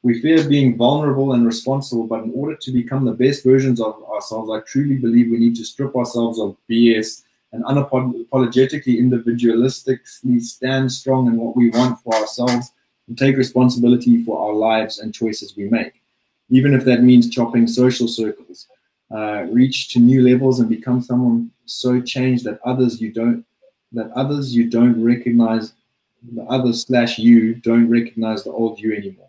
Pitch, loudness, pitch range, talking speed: 120 Hz, -17 LUFS, 115-130 Hz, 170 wpm